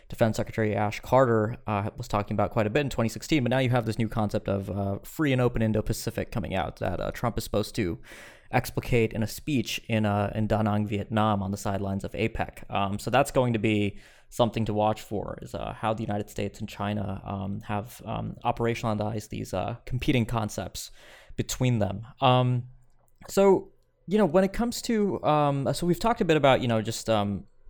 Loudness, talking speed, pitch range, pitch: -27 LUFS, 210 wpm, 105-125 Hz, 110 Hz